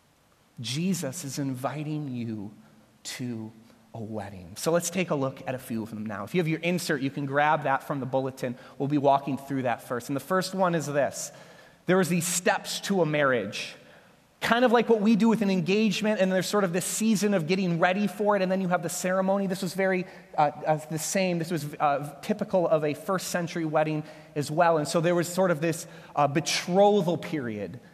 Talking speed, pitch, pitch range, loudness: 215 wpm, 165 Hz, 140-190 Hz, -27 LUFS